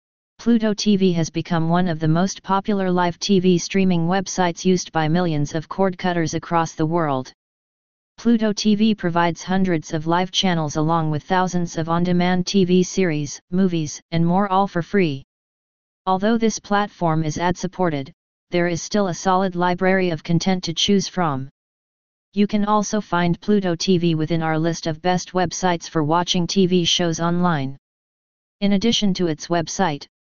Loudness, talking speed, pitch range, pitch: -20 LUFS, 160 wpm, 165-190 Hz, 180 Hz